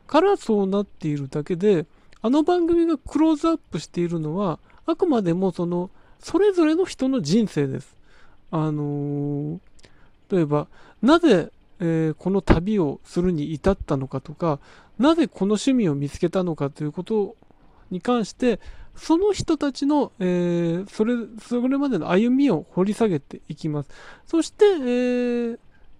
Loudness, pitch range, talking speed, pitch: -23 LUFS, 165-270 Hz, 290 characters per minute, 195 Hz